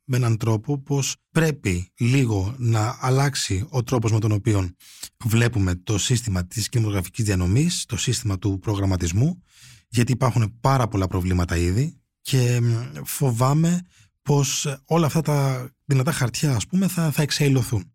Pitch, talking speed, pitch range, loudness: 120 Hz, 140 wpm, 105-140 Hz, -22 LUFS